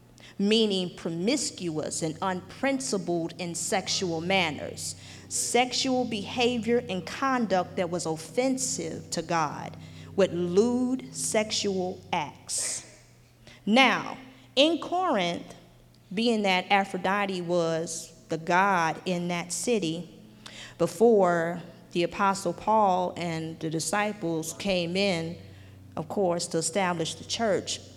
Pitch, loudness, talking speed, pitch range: 180 Hz, -27 LUFS, 100 wpm, 165-215 Hz